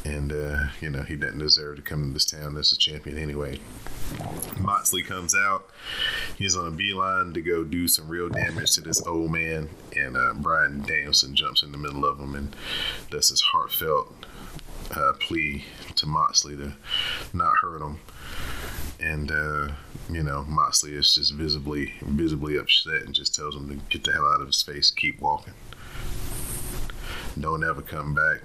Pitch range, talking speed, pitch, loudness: 70-85 Hz, 175 wpm, 75 Hz, -24 LUFS